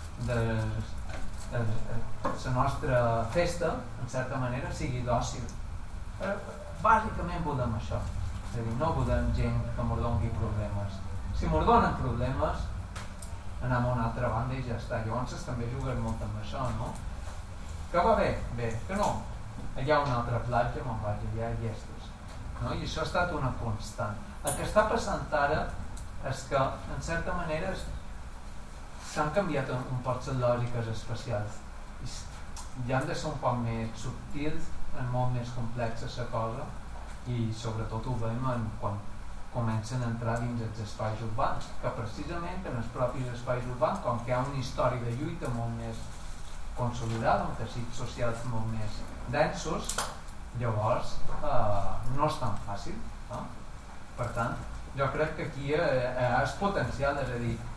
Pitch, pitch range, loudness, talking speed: 115 Hz, 105-125 Hz, -32 LUFS, 160 wpm